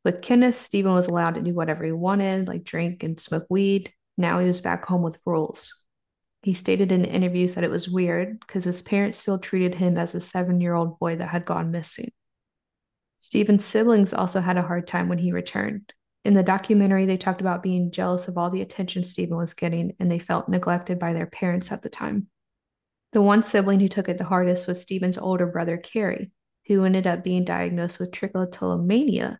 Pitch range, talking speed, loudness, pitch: 175-195 Hz, 200 wpm, -24 LUFS, 180 Hz